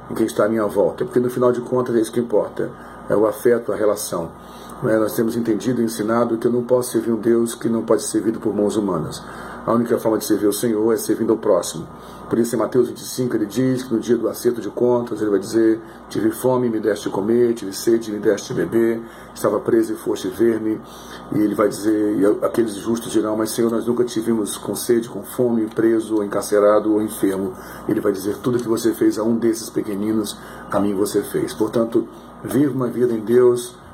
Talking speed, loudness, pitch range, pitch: 230 wpm, -20 LUFS, 110-120 Hz, 115 Hz